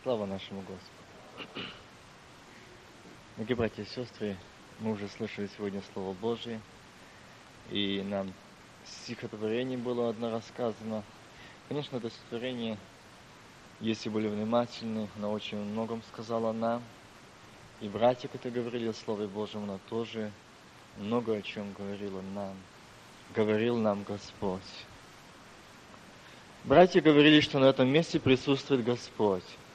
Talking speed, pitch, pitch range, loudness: 110 wpm, 110 Hz, 100-120 Hz, -31 LUFS